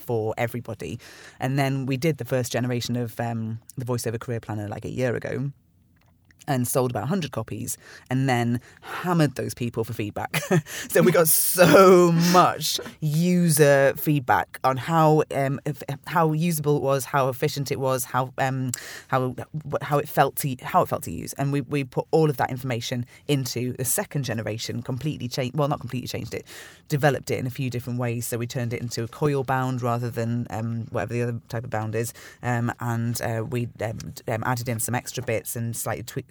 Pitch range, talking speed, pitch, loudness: 120-145 Hz, 200 wpm, 130 Hz, -24 LUFS